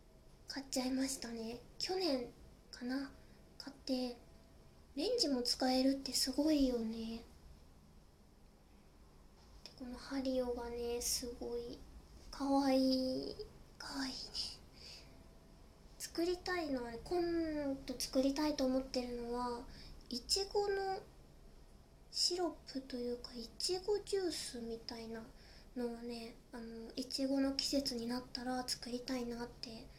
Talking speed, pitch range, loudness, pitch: 225 characters per minute, 230-275 Hz, -39 LUFS, 250 Hz